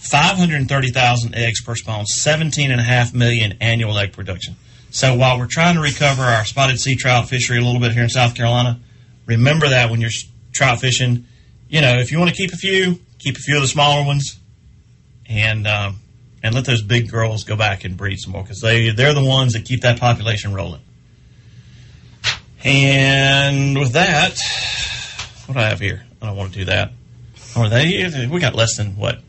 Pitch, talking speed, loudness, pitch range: 120 Hz, 205 wpm, -16 LUFS, 115-135 Hz